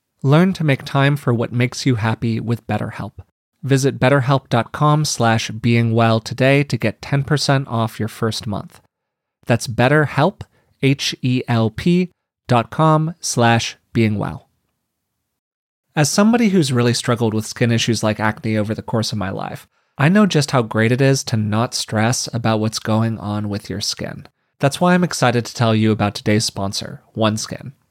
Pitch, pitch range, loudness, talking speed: 120 Hz, 110-140 Hz, -18 LUFS, 160 wpm